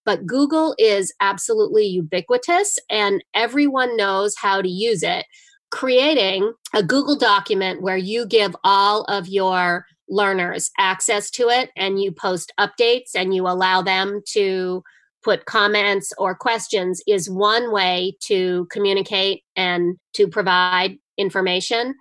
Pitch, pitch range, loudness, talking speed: 200 Hz, 185-235 Hz, -19 LUFS, 130 wpm